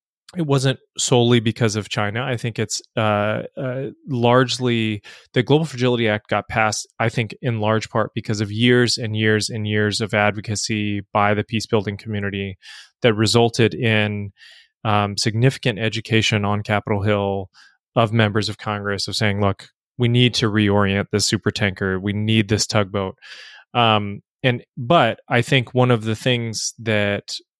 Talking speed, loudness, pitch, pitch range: 160 wpm, -20 LUFS, 110 Hz, 105-120 Hz